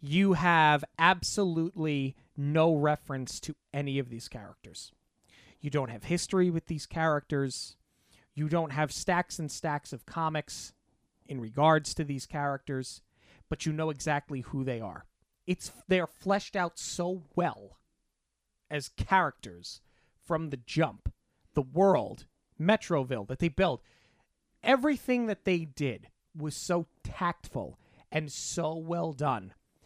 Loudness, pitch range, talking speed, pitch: -31 LUFS, 130-170 Hz, 130 wpm, 150 Hz